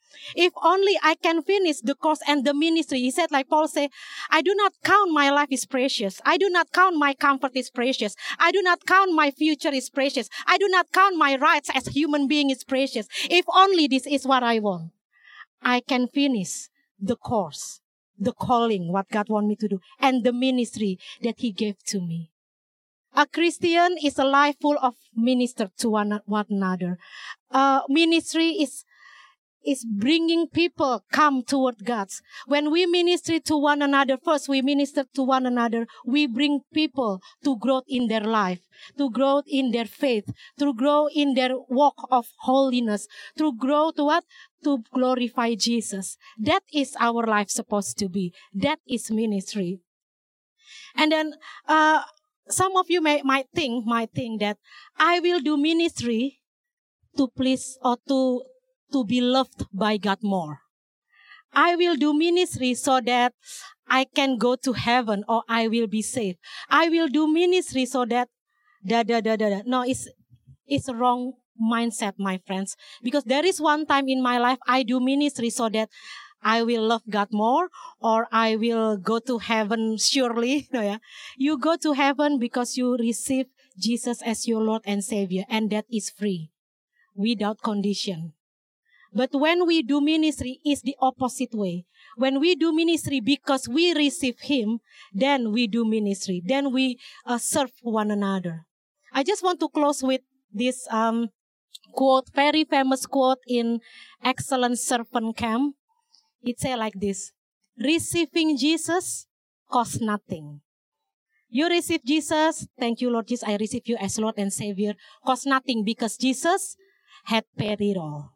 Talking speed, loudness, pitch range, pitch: 165 wpm, -23 LUFS, 225-295 Hz, 260 Hz